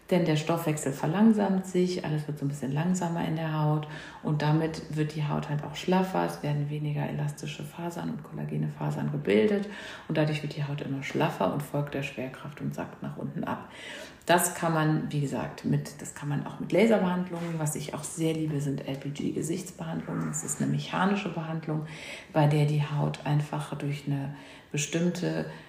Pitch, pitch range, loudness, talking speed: 150 Hz, 140-165 Hz, -29 LUFS, 185 wpm